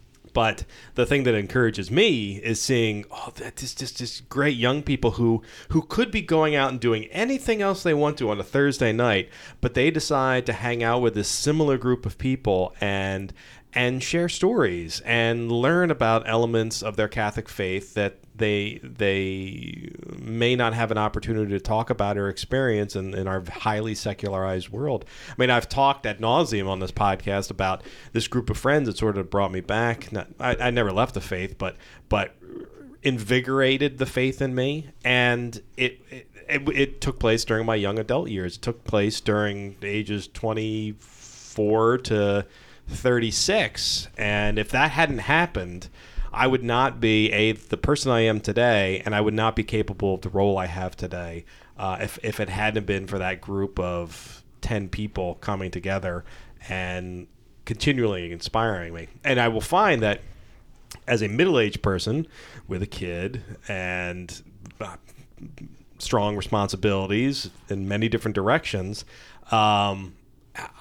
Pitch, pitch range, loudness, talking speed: 110 Hz, 100-125 Hz, -24 LUFS, 165 wpm